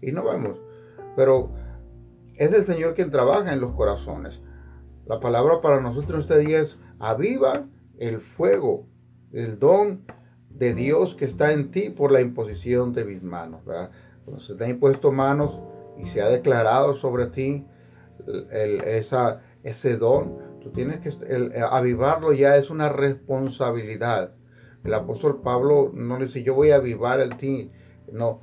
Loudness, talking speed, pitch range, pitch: -22 LUFS, 160 wpm, 110-140 Hz, 125 Hz